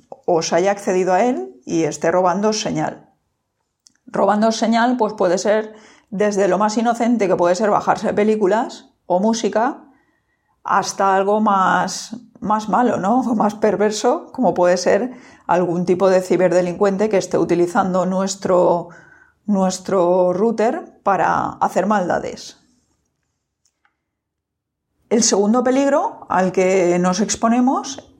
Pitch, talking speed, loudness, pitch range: 200 Hz, 120 wpm, -18 LUFS, 180-225 Hz